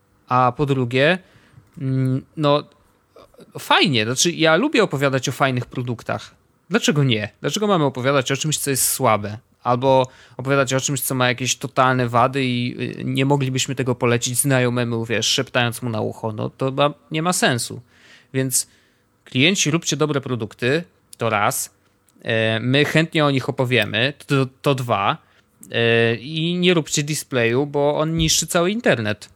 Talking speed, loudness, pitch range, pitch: 145 wpm, -19 LUFS, 120-145 Hz, 130 Hz